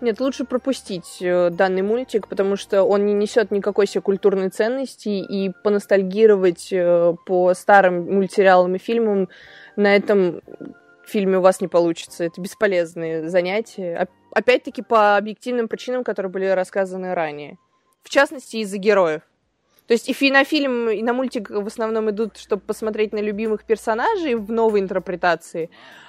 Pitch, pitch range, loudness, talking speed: 205 Hz, 185-225 Hz, -20 LUFS, 145 wpm